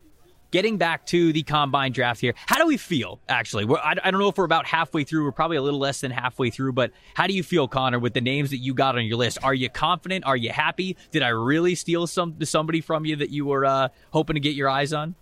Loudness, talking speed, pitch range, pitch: -23 LUFS, 270 wpm, 135-165 Hz, 150 Hz